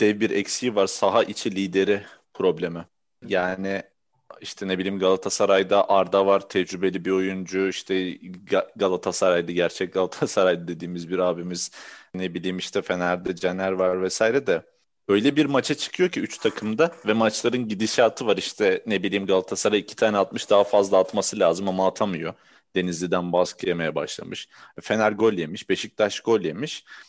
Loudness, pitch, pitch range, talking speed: -23 LUFS, 95 Hz, 90-105 Hz, 150 wpm